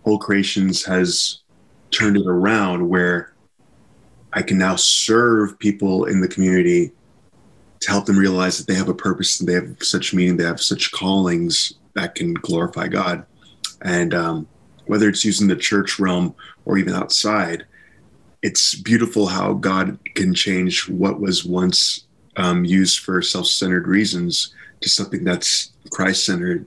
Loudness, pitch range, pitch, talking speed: -18 LUFS, 90-100 Hz, 95 Hz, 155 wpm